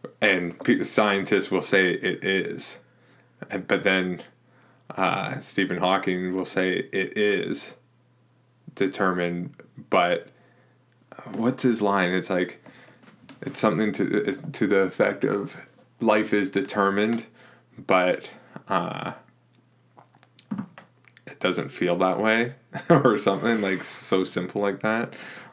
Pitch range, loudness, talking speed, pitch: 95-125 Hz, -24 LUFS, 115 wpm, 105 Hz